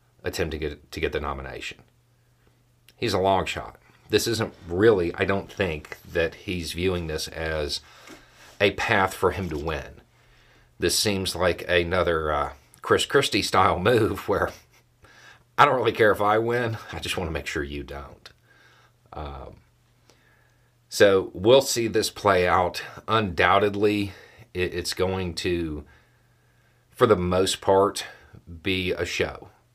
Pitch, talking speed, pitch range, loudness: 95 Hz, 145 wpm, 85-110 Hz, -24 LUFS